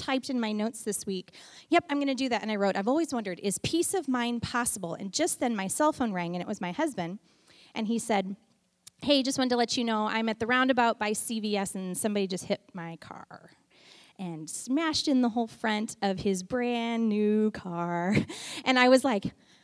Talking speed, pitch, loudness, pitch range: 215 wpm, 220 Hz, -28 LUFS, 195-255 Hz